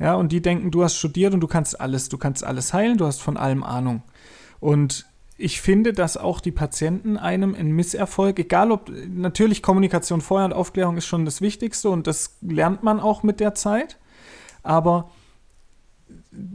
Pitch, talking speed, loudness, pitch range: 175 Hz, 180 wpm, -21 LUFS, 155-195 Hz